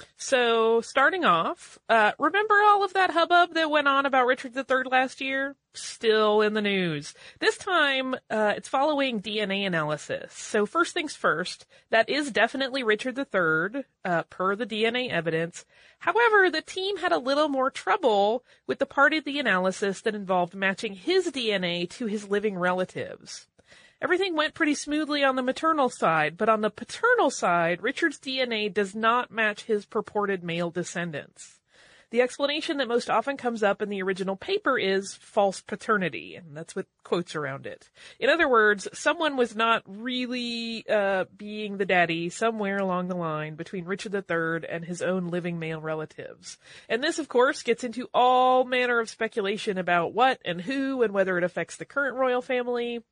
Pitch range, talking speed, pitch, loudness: 195-275 Hz, 175 wpm, 225 Hz, -25 LUFS